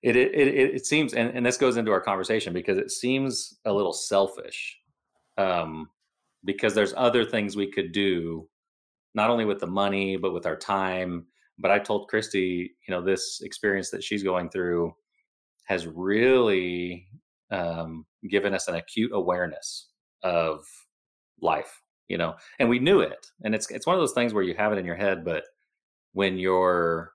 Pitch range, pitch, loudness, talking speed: 90-120 Hz, 100 Hz, -26 LUFS, 175 wpm